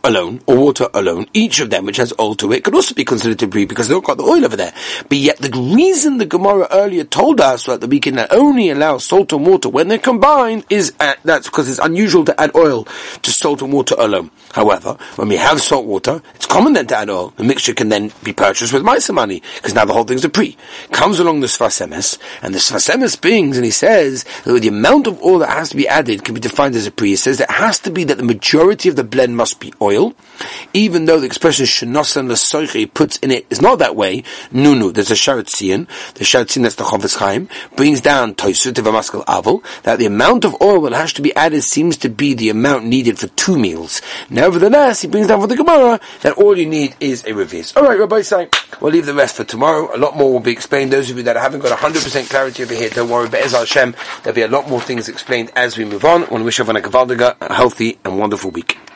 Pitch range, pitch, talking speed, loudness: 125-200 Hz, 140 Hz, 240 wpm, -13 LUFS